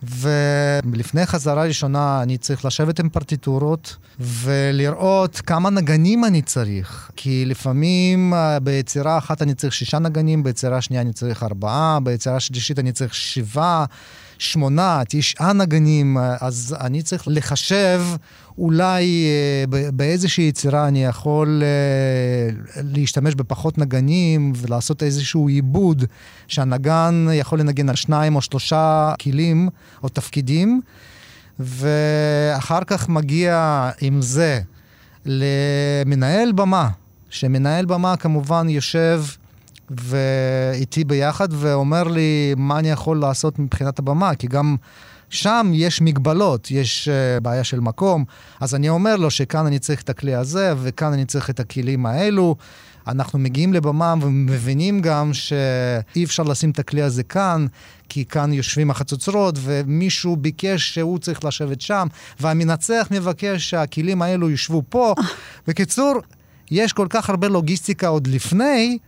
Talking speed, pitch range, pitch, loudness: 120 wpm, 135-165 Hz, 145 Hz, -19 LUFS